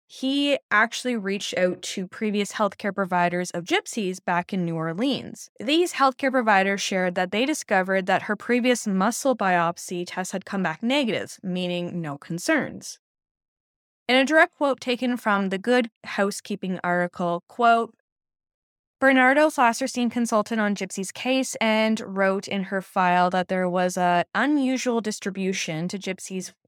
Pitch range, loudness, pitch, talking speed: 185-250 Hz, -24 LUFS, 205 Hz, 145 wpm